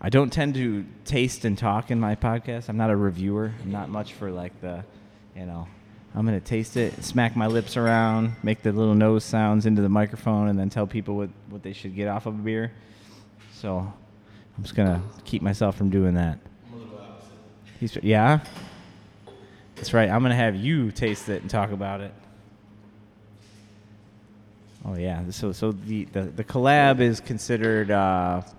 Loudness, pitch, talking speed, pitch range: -24 LUFS, 105 Hz, 185 wpm, 100-110 Hz